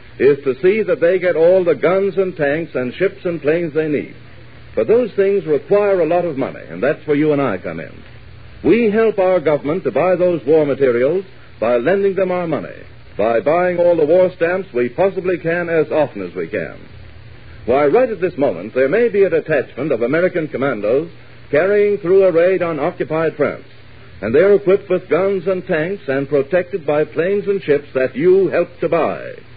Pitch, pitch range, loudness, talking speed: 180 Hz, 150-195 Hz, -16 LUFS, 205 wpm